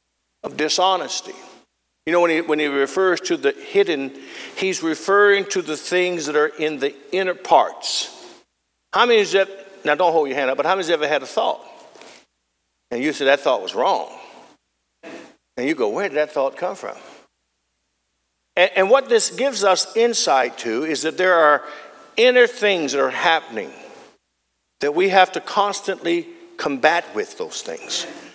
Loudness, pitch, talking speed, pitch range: -19 LUFS, 175 Hz, 180 wpm, 140-205 Hz